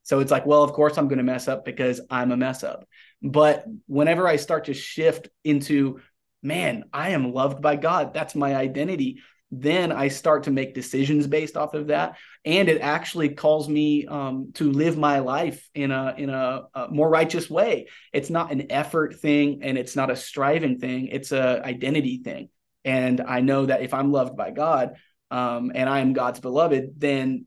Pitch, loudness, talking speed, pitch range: 140 Hz, -23 LUFS, 200 wpm, 130-150 Hz